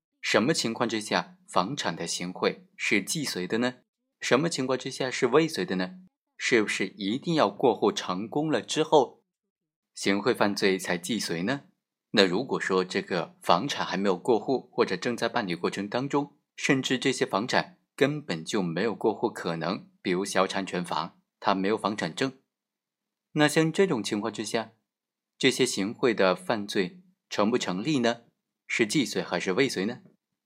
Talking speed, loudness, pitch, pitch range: 250 characters per minute, -27 LUFS, 130 Hz, 105-155 Hz